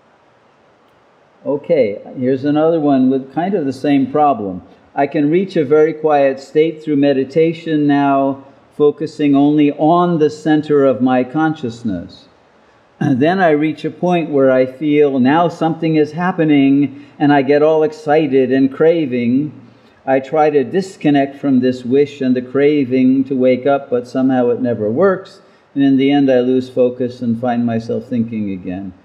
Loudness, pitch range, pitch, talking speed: -15 LUFS, 130-155 Hz, 140 Hz, 160 wpm